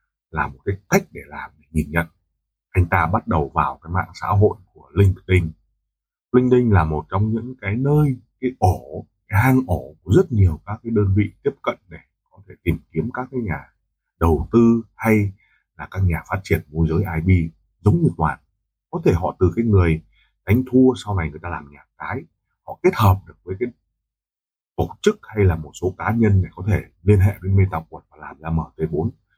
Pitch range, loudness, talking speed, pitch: 80-110 Hz, -20 LUFS, 215 wpm, 95 Hz